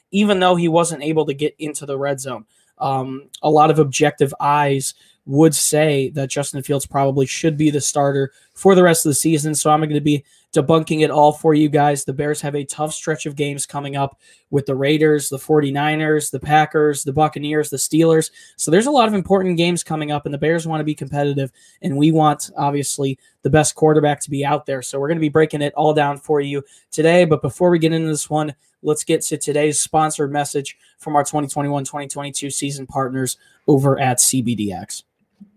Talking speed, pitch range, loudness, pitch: 215 wpm, 140-155 Hz, -18 LUFS, 150 Hz